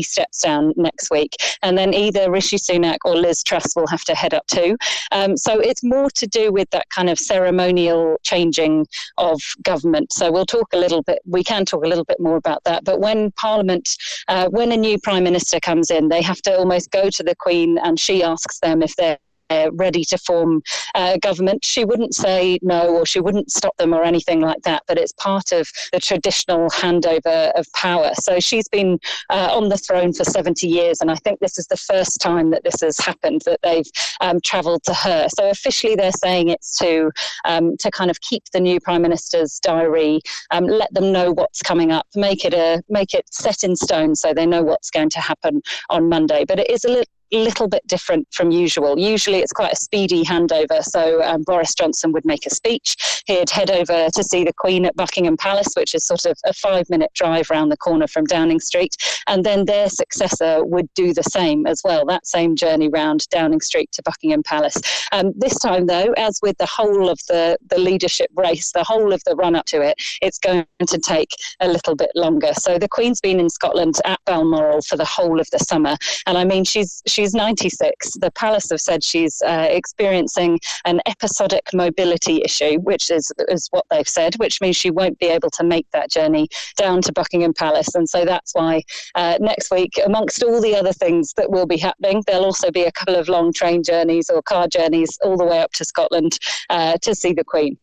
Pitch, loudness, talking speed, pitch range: 180 Hz, -17 LUFS, 215 wpm, 170-210 Hz